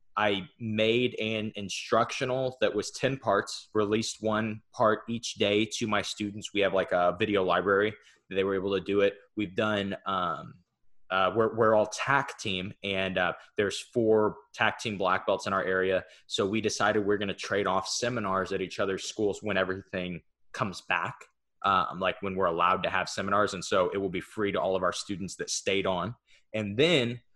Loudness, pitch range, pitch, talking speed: -29 LUFS, 95-110 Hz, 105 Hz, 195 wpm